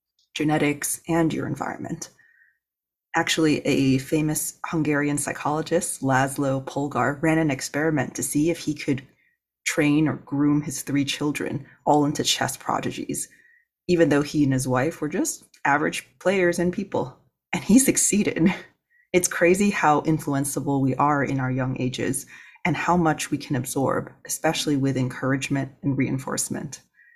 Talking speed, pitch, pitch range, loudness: 145 wpm, 150 Hz, 135-165 Hz, -23 LUFS